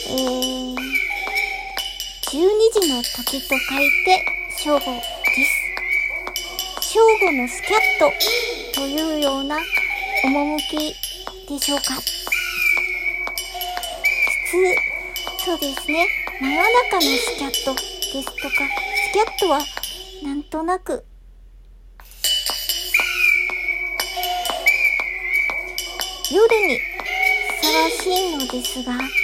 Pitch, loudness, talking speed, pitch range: 360 Hz, -19 LUFS, 150 characters per minute, 285-385 Hz